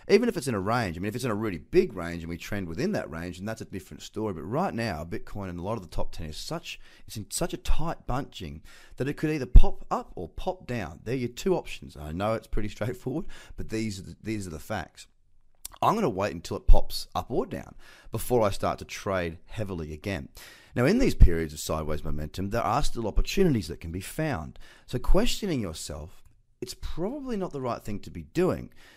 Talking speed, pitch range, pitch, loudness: 235 wpm, 85-120 Hz, 100 Hz, -30 LUFS